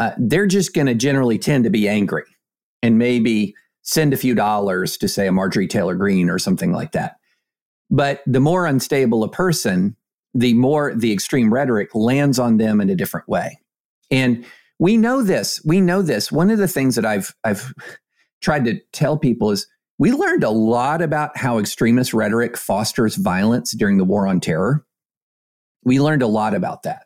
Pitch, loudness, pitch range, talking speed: 120 Hz, -18 LUFS, 110-150 Hz, 185 wpm